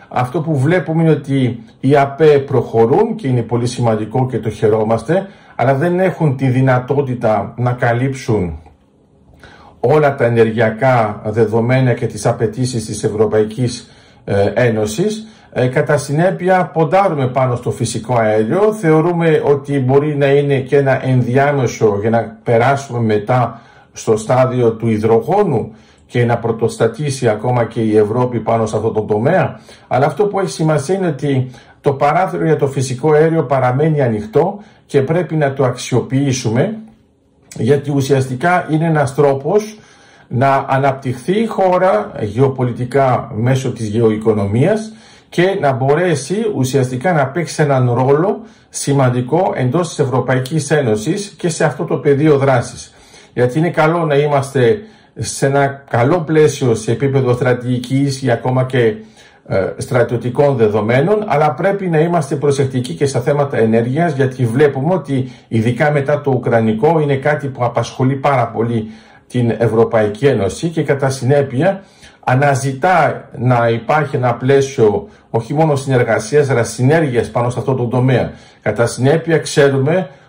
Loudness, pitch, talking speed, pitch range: -15 LUFS, 135 Hz, 135 wpm, 115-150 Hz